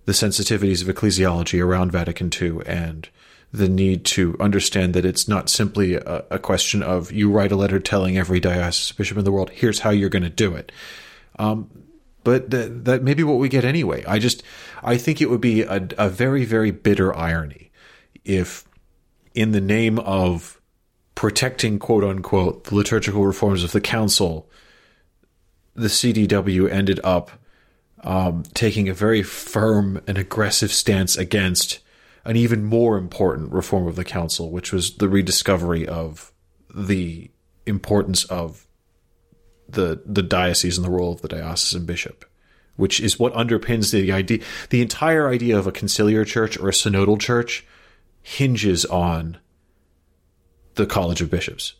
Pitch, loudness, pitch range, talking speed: 100 Hz, -20 LUFS, 90-110 Hz, 160 wpm